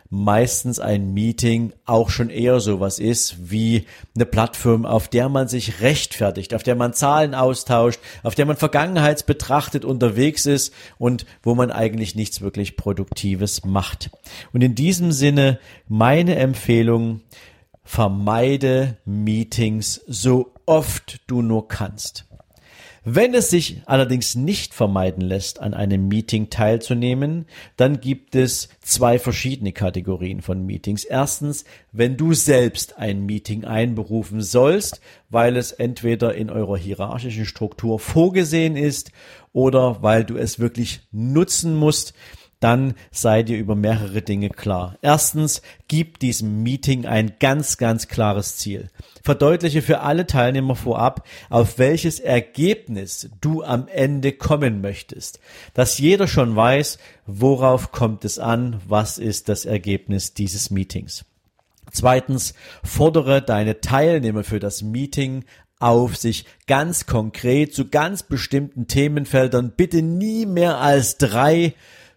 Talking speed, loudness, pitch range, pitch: 130 wpm, -19 LUFS, 105-135 Hz, 120 Hz